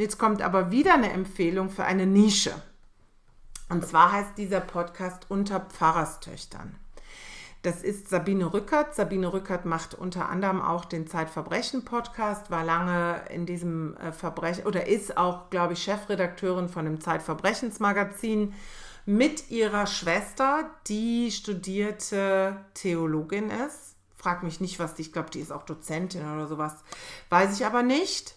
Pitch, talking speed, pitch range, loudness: 190 Hz, 140 wpm, 170-205 Hz, -27 LUFS